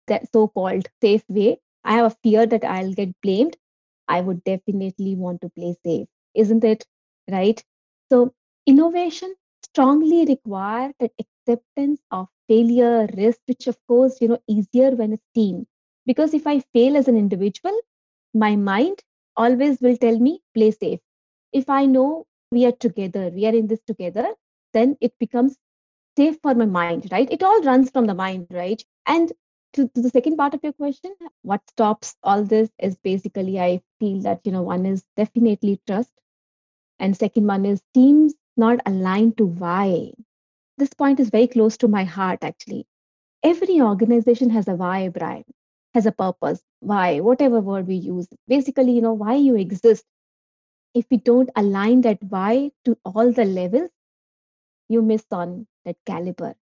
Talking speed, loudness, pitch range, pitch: 165 wpm, -20 LUFS, 200-260 Hz, 230 Hz